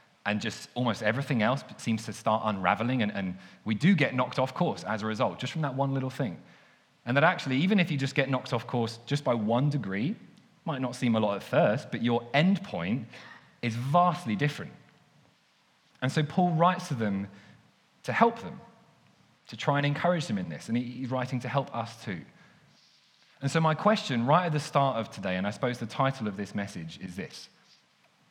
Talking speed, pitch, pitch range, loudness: 210 wpm, 130 Hz, 110-150 Hz, -29 LUFS